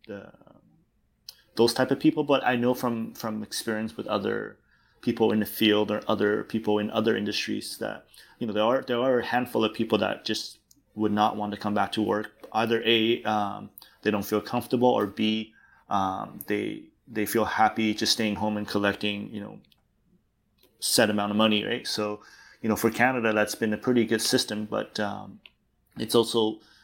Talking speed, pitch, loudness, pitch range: 190 wpm, 110 Hz, -26 LUFS, 105-115 Hz